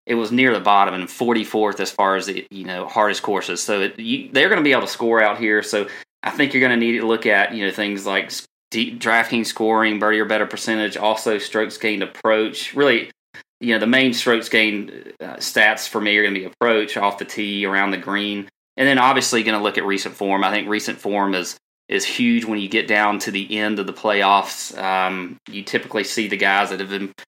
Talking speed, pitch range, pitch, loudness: 240 wpm, 100-115 Hz, 105 Hz, -19 LUFS